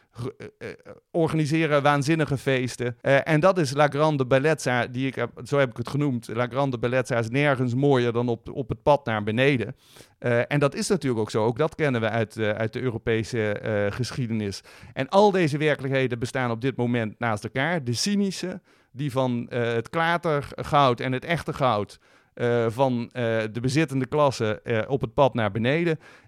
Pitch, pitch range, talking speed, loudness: 130 Hz, 120-145 Hz, 185 wpm, -24 LUFS